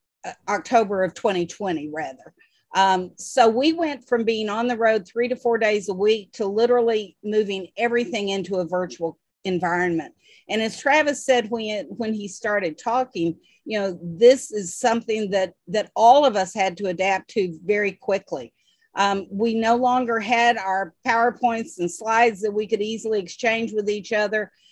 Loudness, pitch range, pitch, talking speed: -22 LUFS, 195-235 Hz, 215 Hz, 165 wpm